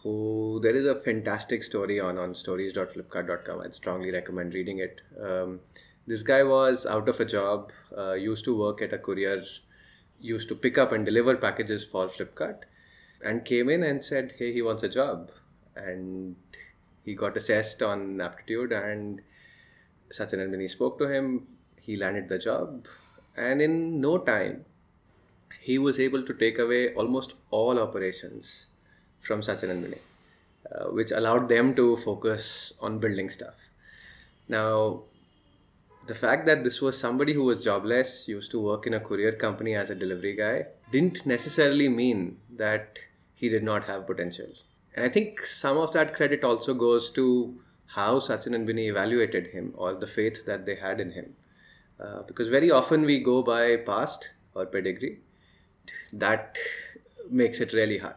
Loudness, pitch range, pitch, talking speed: -27 LUFS, 100-130 Hz, 110 Hz, 165 wpm